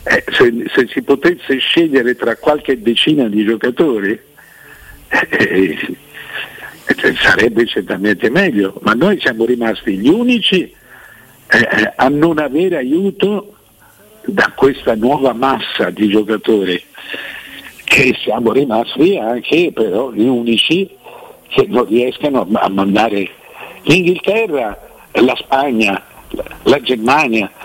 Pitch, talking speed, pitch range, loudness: 130 Hz, 110 wpm, 115-175 Hz, -13 LUFS